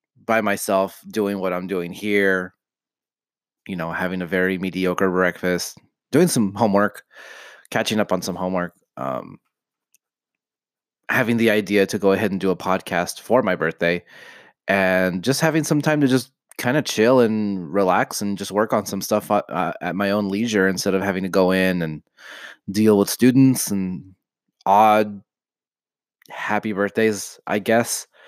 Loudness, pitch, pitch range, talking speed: -20 LUFS, 100 Hz, 95-105 Hz, 160 wpm